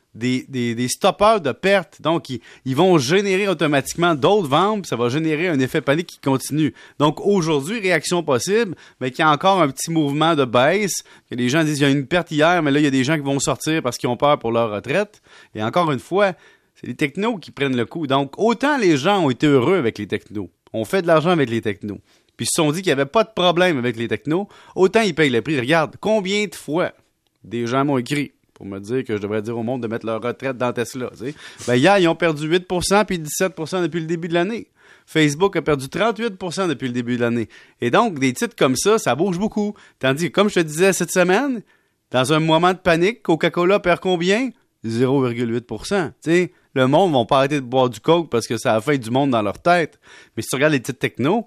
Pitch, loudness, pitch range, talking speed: 155 Hz, -19 LUFS, 130-180 Hz, 245 wpm